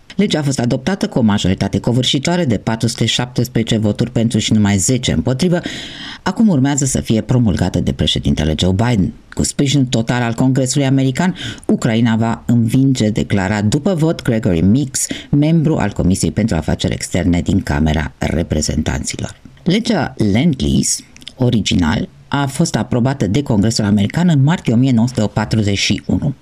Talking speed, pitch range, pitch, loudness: 140 wpm, 100-140 Hz, 115 Hz, -15 LUFS